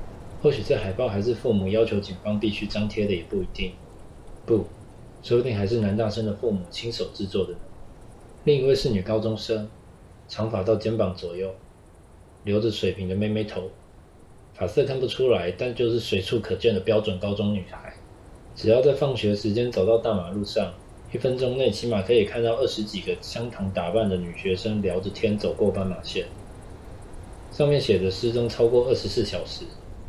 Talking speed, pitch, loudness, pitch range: 275 characters per minute, 105 Hz, -25 LUFS, 95-115 Hz